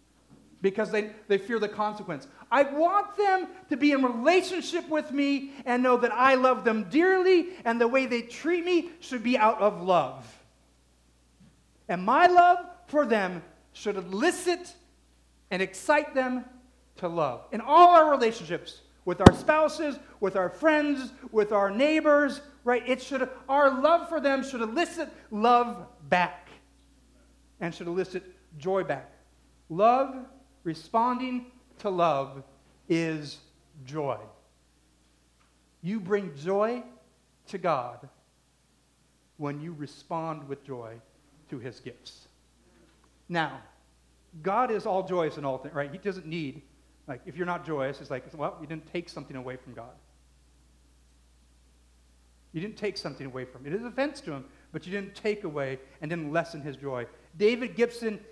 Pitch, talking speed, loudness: 195 Hz, 150 wpm, -27 LUFS